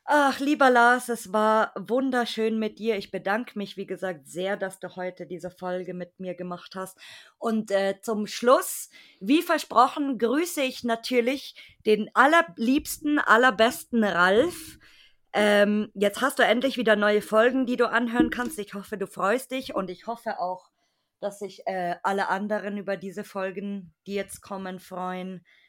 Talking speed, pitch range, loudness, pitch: 160 wpm, 190-240 Hz, -25 LUFS, 210 Hz